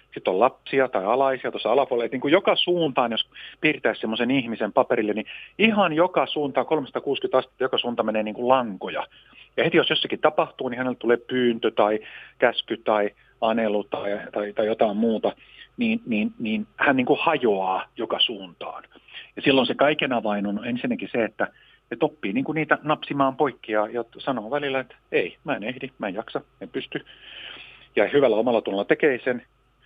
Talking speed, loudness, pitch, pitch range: 175 wpm, -24 LUFS, 130 Hz, 115-155 Hz